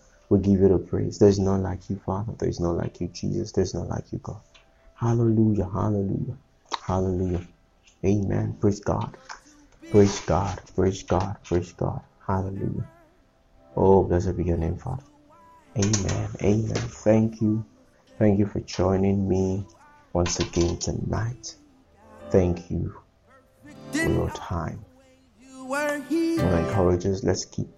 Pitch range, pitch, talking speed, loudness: 90-115 Hz, 100 Hz, 135 wpm, -25 LUFS